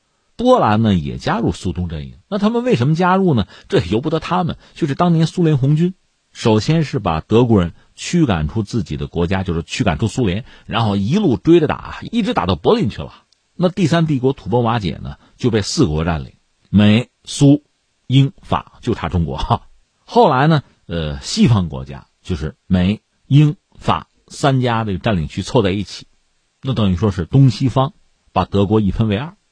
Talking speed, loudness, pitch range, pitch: 270 characters per minute, -17 LUFS, 90-155 Hz, 115 Hz